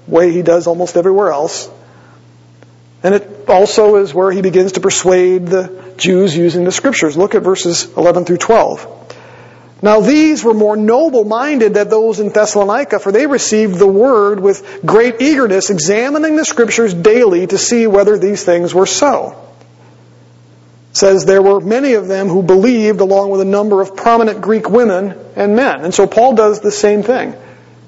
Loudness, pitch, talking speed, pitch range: -11 LUFS, 195 Hz, 175 wpm, 180-220 Hz